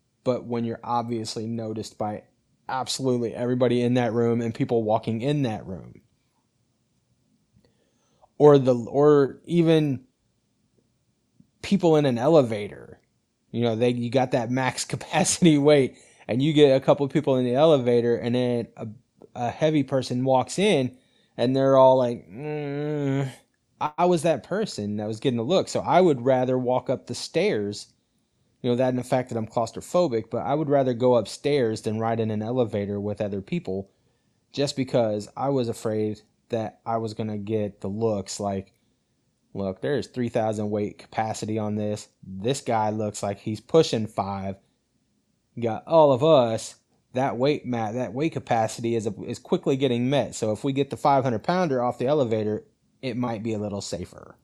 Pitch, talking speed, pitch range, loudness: 120 Hz, 175 wpm, 110-135 Hz, -24 LUFS